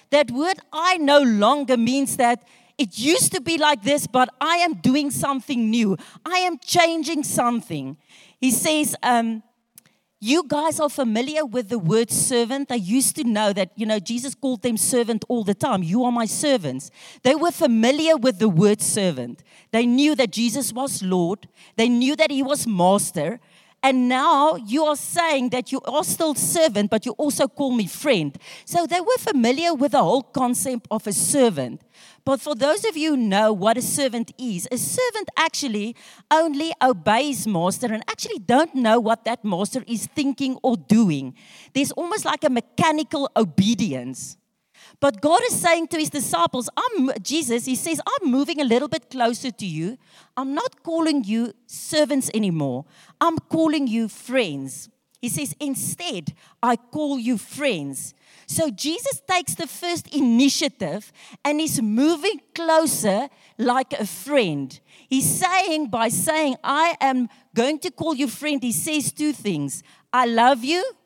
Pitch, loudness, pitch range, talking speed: 255 Hz, -21 LUFS, 220-300 Hz, 170 wpm